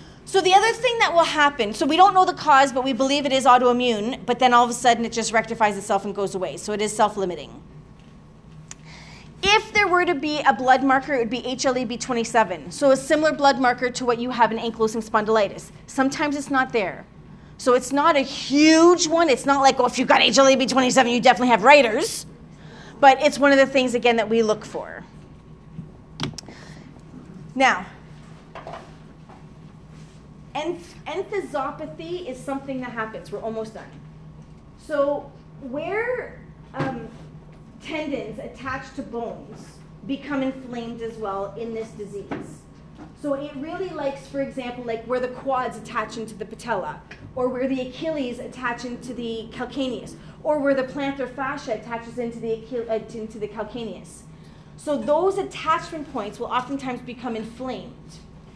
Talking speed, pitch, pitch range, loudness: 165 wpm, 255 Hz, 230-280 Hz, -21 LUFS